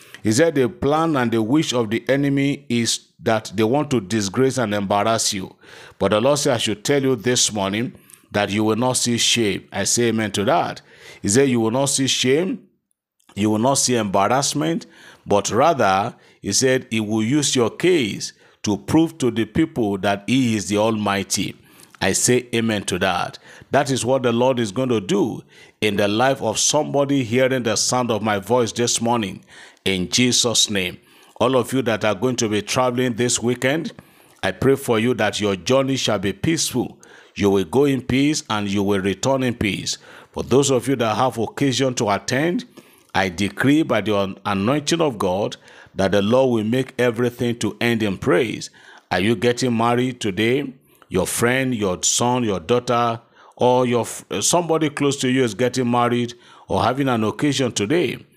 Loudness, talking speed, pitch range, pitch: -20 LUFS, 190 wpm, 105-130 Hz, 120 Hz